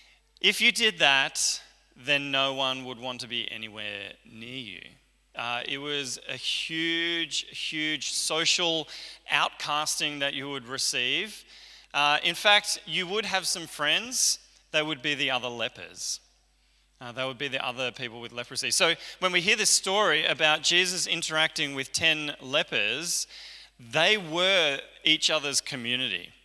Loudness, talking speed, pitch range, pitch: -25 LUFS, 150 wpm, 130-170 Hz, 150 Hz